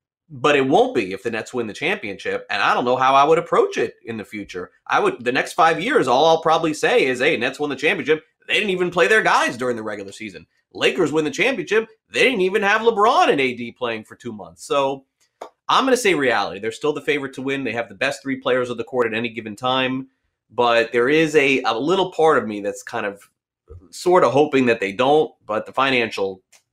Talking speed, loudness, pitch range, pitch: 245 wpm, -19 LUFS, 115-160 Hz, 135 Hz